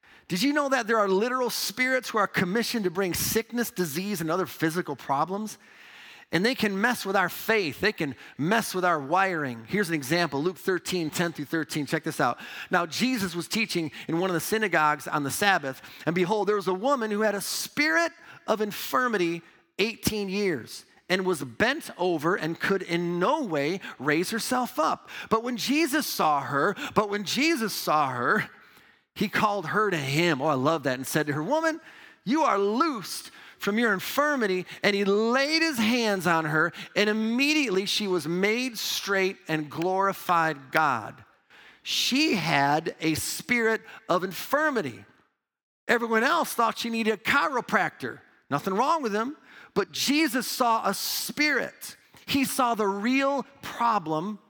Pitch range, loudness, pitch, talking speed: 170-230 Hz, -26 LUFS, 200 Hz, 170 wpm